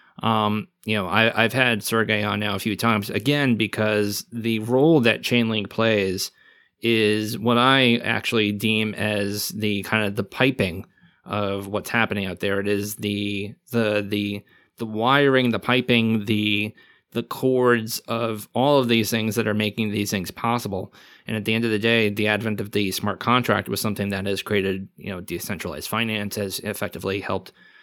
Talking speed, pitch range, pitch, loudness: 180 wpm, 100-115 Hz, 105 Hz, -22 LUFS